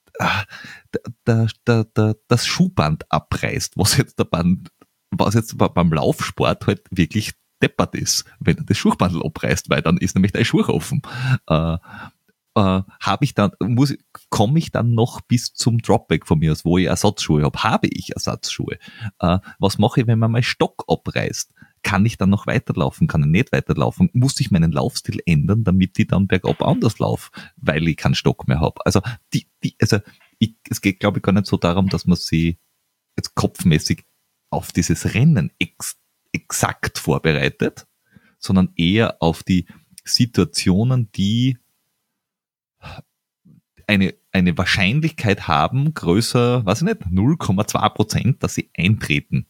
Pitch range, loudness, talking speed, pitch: 90-115 Hz, -19 LUFS, 155 wpm, 100 Hz